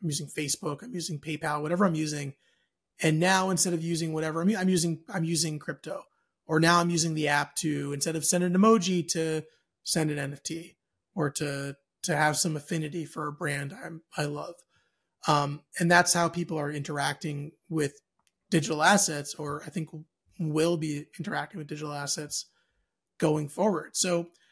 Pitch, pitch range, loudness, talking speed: 160 Hz, 150-170 Hz, -28 LUFS, 170 wpm